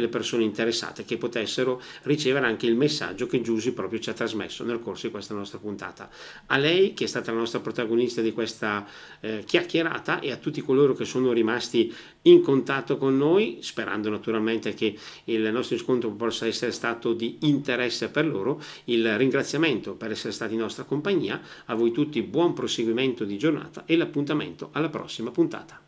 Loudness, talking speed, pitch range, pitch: -26 LUFS, 180 wpm, 110-135 Hz, 115 Hz